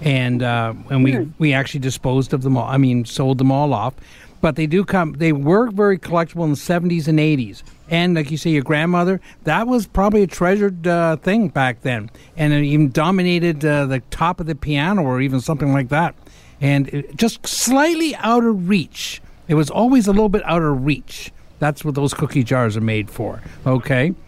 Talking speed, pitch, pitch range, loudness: 210 wpm, 150 Hz, 135-175 Hz, -18 LUFS